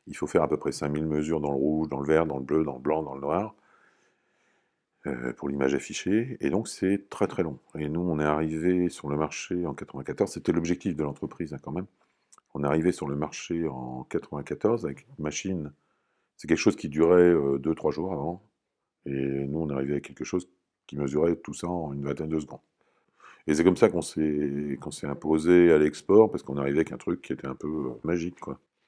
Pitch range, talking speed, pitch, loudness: 70-85 Hz, 230 wpm, 75 Hz, -27 LUFS